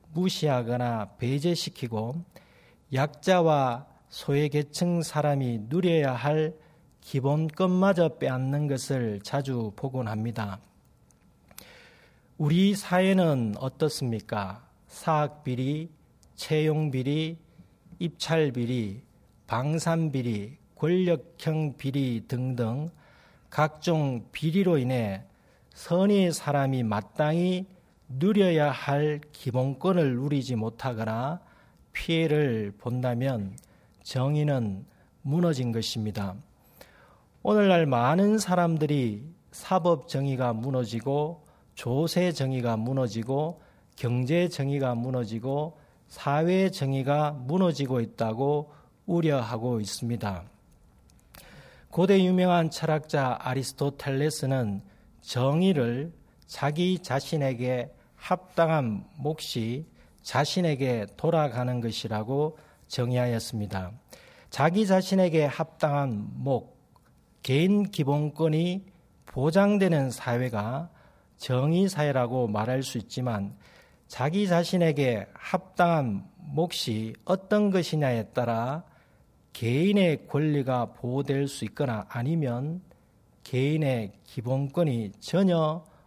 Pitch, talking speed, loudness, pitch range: 140 Hz, 215 characters per minute, -27 LUFS, 125-165 Hz